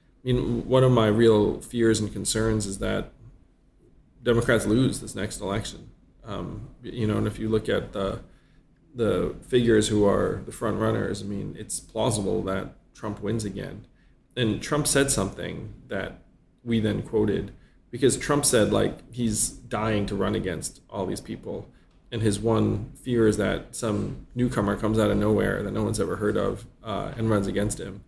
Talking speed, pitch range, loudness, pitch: 175 wpm, 105-115 Hz, -25 LUFS, 110 Hz